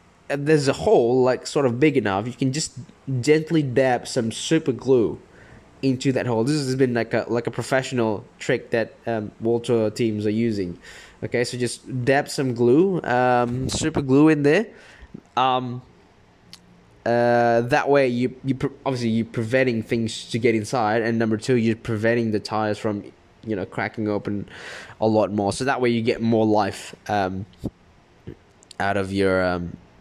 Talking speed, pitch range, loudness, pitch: 170 wpm, 110-130 Hz, -22 LUFS, 120 Hz